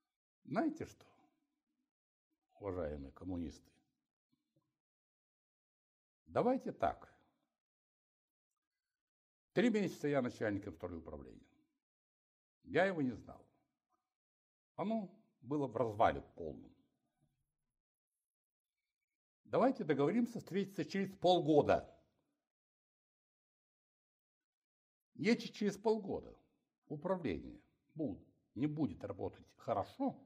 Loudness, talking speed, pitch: -38 LUFS, 70 wpm, 220 Hz